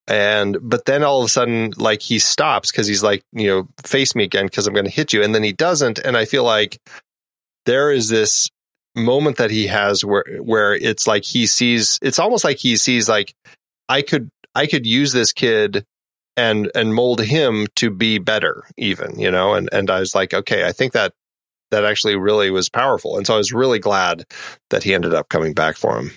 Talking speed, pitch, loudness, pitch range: 220 wpm, 105 Hz, -17 LUFS, 100-115 Hz